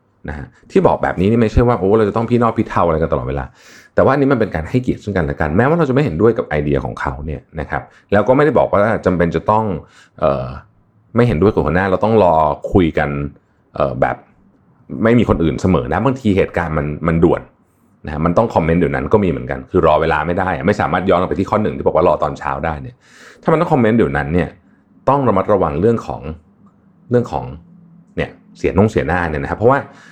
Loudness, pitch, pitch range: -16 LUFS, 85 Hz, 75-110 Hz